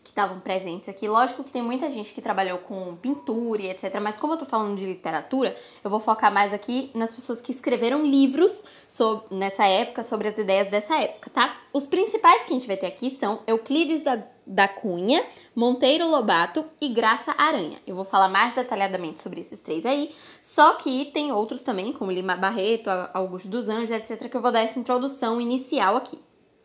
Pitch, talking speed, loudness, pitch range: 230 Hz, 195 wpm, -24 LUFS, 200-275 Hz